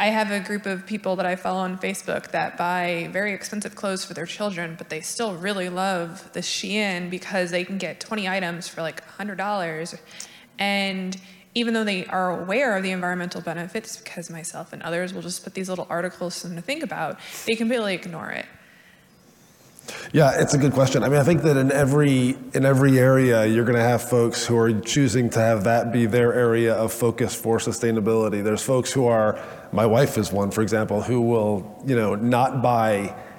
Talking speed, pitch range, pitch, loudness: 205 wpm, 120-190 Hz, 170 Hz, -23 LUFS